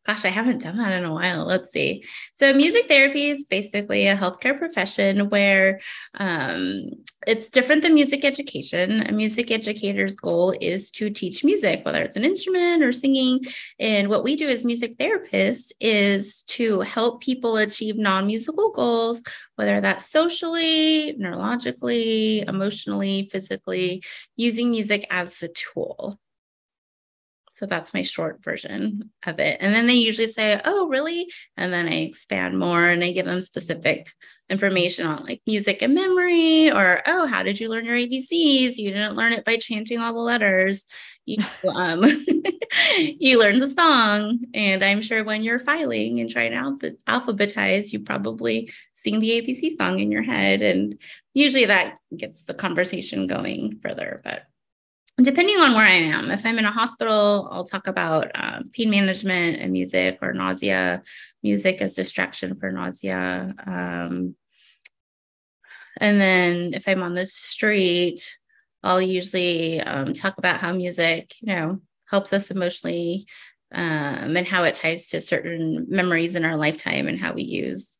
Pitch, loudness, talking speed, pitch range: 205 Hz, -21 LUFS, 160 wpm, 175-245 Hz